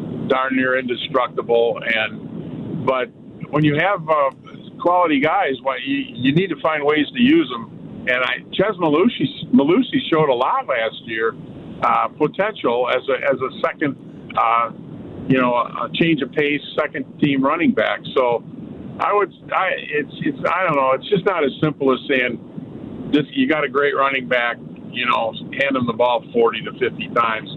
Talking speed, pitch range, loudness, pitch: 175 wpm, 130-175 Hz, -19 LUFS, 145 Hz